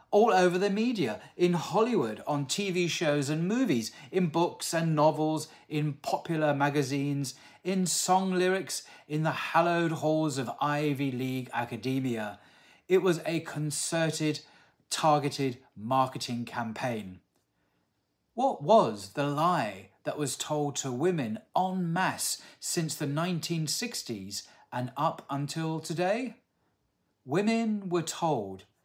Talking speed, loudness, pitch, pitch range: 120 wpm, -29 LUFS, 155 Hz, 135-175 Hz